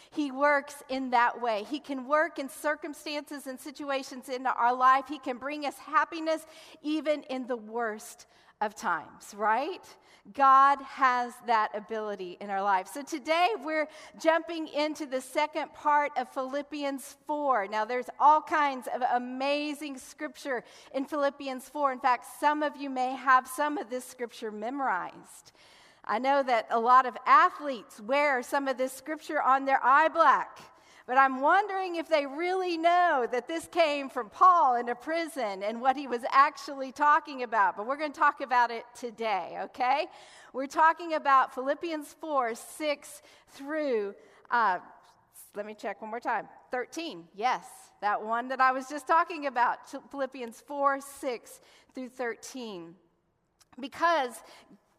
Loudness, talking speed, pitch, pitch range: -28 LUFS, 155 wpm, 275 Hz, 250-300 Hz